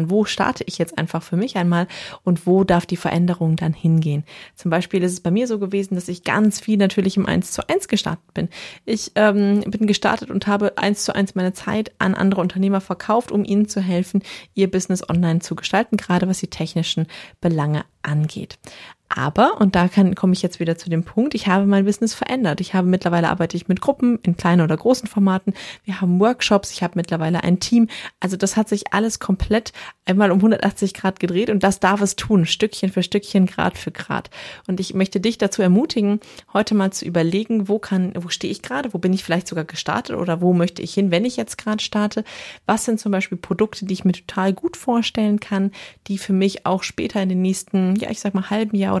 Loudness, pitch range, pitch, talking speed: -20 LUFS, 180-205 Hz, 195 Hz, 220 wpm